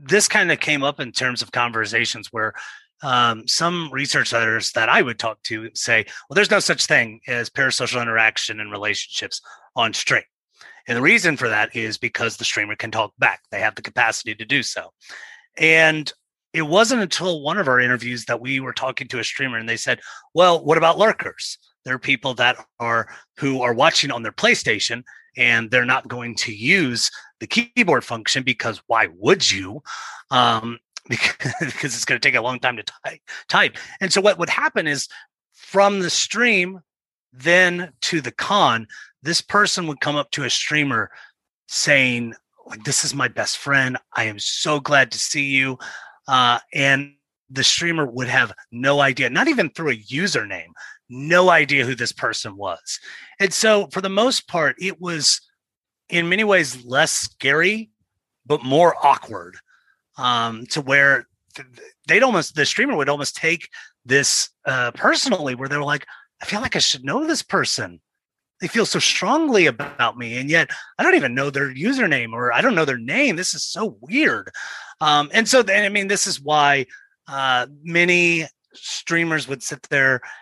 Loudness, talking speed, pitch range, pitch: -19 LUFS, 180 wpm, 125-180 Hz, 145 Hz